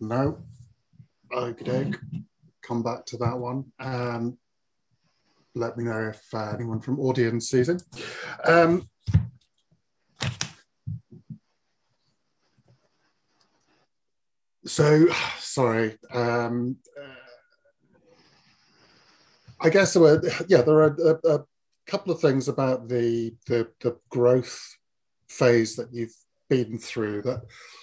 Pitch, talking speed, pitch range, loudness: 125 Hz, 105 wpm, 120-145 Hz, -24 LUFS